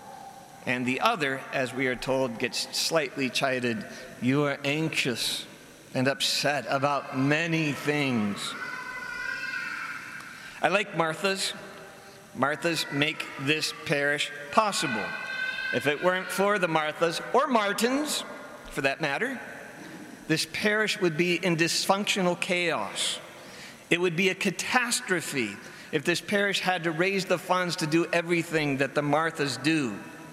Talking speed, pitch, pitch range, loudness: 125 wpm, 170 Hz, 145-200 Hz, -27 LUFS